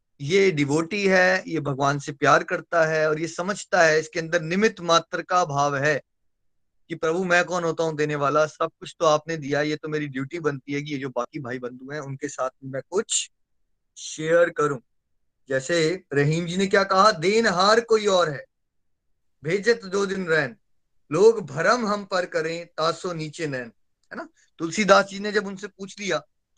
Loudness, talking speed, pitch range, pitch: -23 LUFS, 190 wpm, 150-190 Hz, 165 Hz